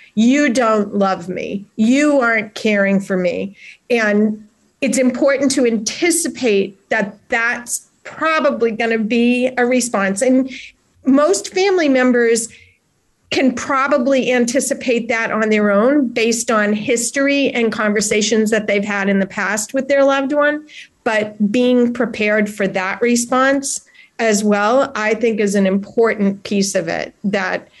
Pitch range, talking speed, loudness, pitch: 210-265 Hz, 140 wpm, -16 LUFS, 230 Hz